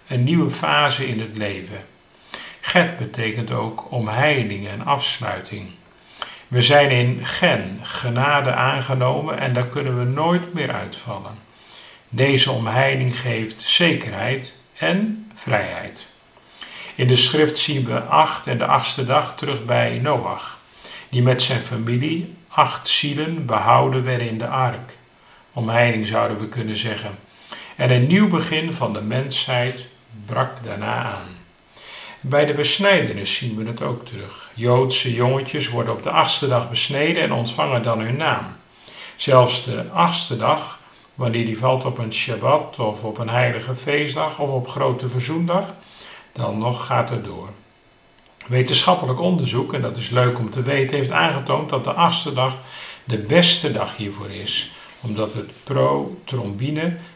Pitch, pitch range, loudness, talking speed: 125 Hz, 115-145 Hz, -19 LUFS, 145 wpm